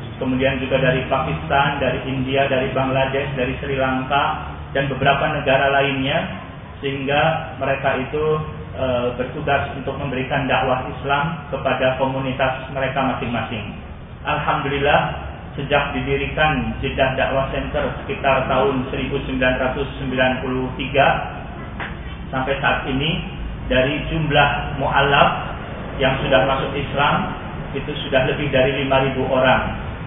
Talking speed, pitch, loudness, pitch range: 105 wpm, 135 Hz, -20 LUFS, 130-140 Hz